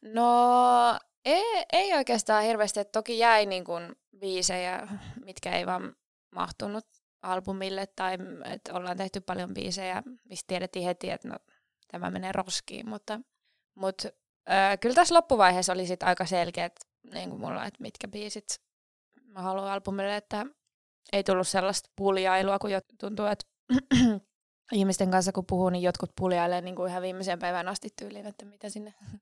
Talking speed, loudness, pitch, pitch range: 150 wpm, -28 LUFS, 195 Hz, 185-220 Hz